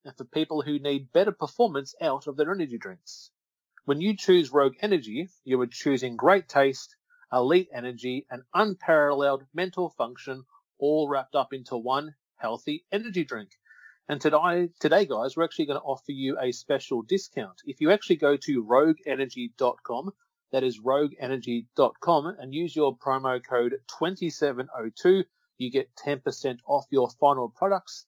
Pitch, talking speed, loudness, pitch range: 145 Hz, 150 wpm, -27 LUFS, 135-180 Hz